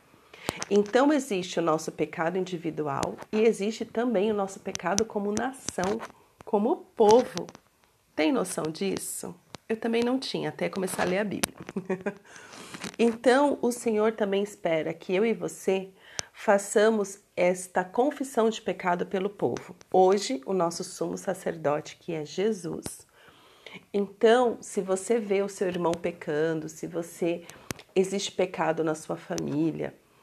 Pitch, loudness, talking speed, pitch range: 195 Hz, -28 LUFS, 135 wpm, 175-225 Hz